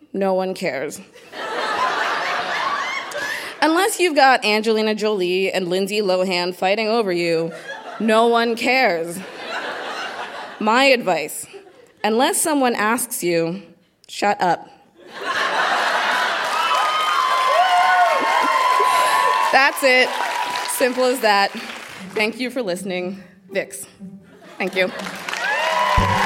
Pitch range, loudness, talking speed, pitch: 185-265 Hz, -19 LUFS, 85 wpm, 215 Hz